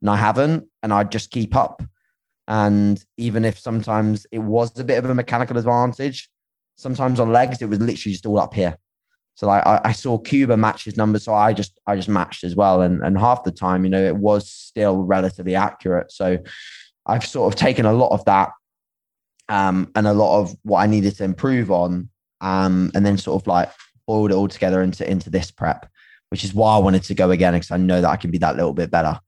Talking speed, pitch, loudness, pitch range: 230 wpm, 100 Hz, -19 LUFS, 95-115 Hz